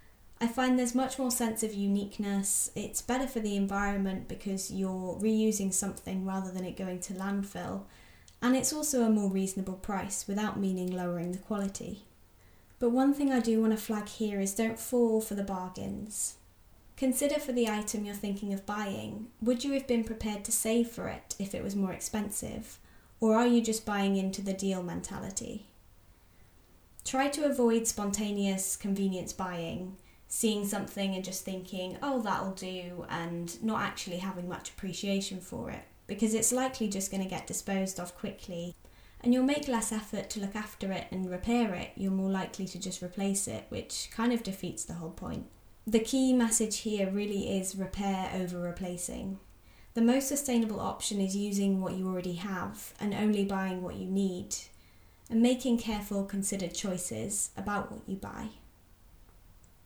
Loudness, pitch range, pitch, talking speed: -32 LUFS, 185-225 Hz, 200 Hz, 175 wpm